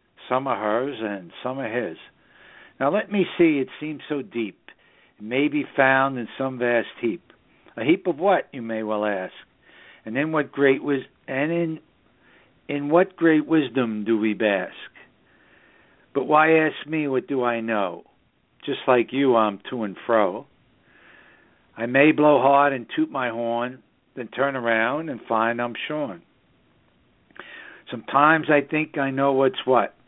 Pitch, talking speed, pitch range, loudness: 135 Hz, 165 wpm, 120-150 Hz, -22 LUFS